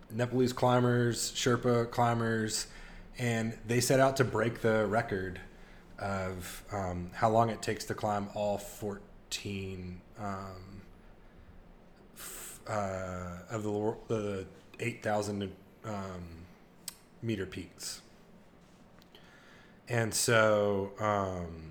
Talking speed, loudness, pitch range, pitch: 90 wpm, -32 LUFS, 95-115 Hz, 105 Hz